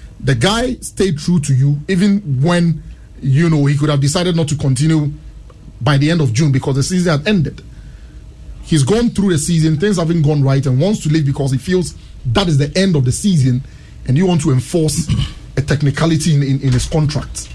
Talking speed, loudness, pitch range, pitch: 210 wpm, -15 LUFS, 135-170 Hz, 150 Hz